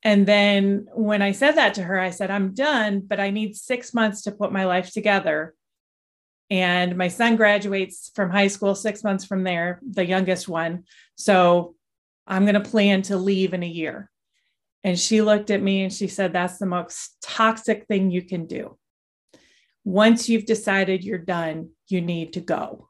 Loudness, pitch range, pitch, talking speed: -22 LUFS, 180-210 Hz, 195 Hz, 185 wpm